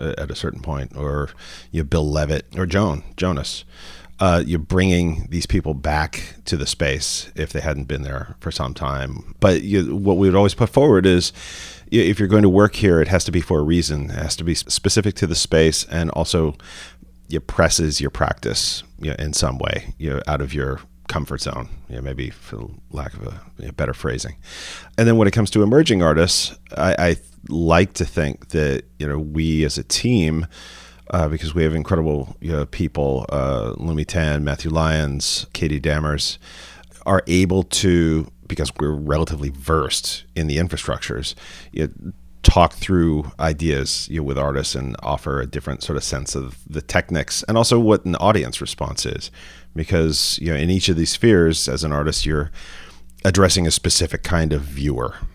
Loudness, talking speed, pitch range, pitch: -20 LUFS, 195 wpm, 70-90 Hz, 80 Hz